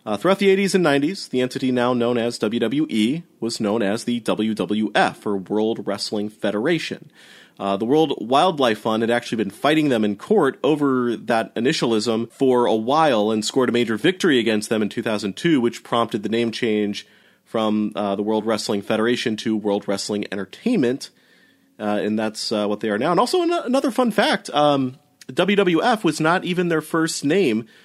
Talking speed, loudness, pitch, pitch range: 185 wpm, -21 LUFS, 115 Hz, 105-145 Hz